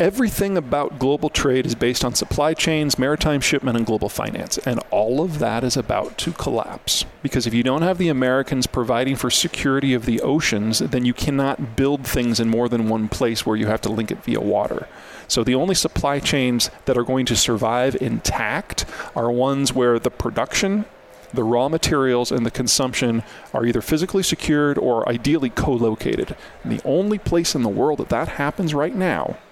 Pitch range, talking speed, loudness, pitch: 120-145 Hz, 190 wpm, -20 LUFS, 130 Hz